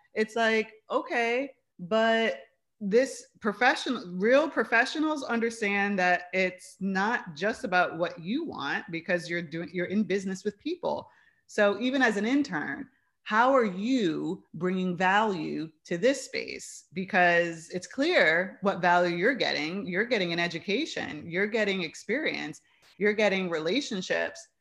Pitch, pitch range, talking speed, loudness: 205 Hz, 180-245 Hz, 135 wpm, -28 LUFS